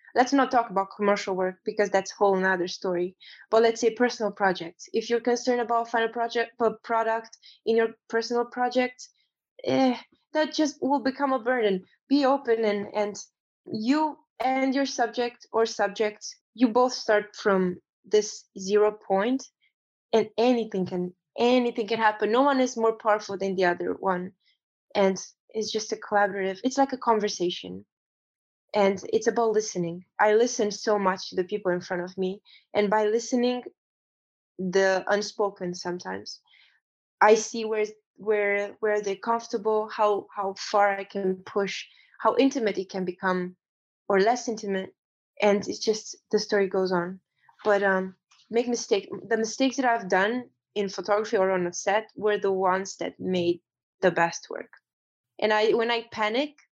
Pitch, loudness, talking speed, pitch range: 215 Hz, -26 LUFS, 165 wpm, 195-235 Hz